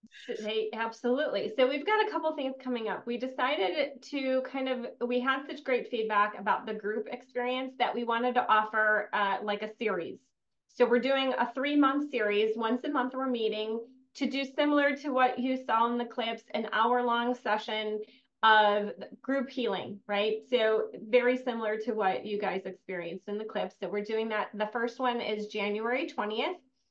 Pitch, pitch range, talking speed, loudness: 235 Hz, 215-260 Hz, 185 wpm, -30 LUFS